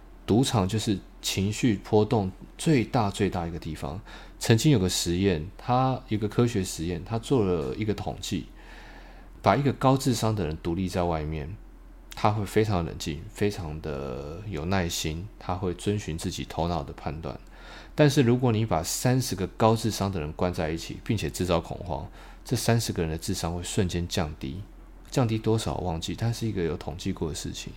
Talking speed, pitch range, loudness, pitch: 270 characters per minute, 85-110 Hz, -27 LUFS, 95 Hz